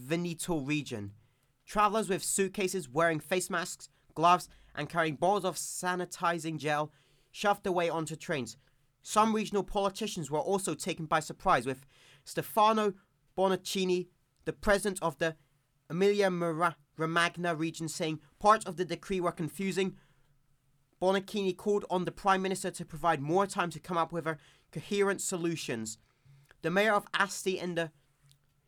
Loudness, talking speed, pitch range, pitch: -31 LUFS, 140 wpm, 145-190 Hz, 170 Hz